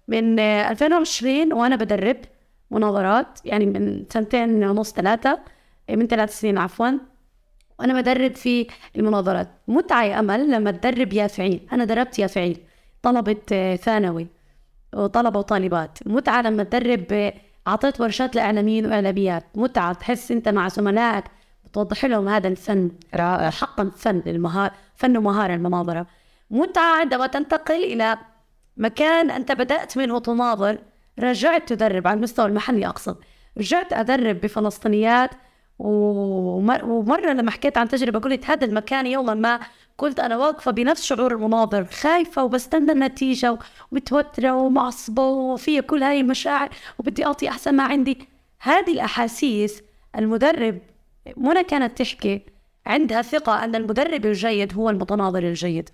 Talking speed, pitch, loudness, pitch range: 125 wpm, 230 Hz, -21 LUFS, 210-265 Hz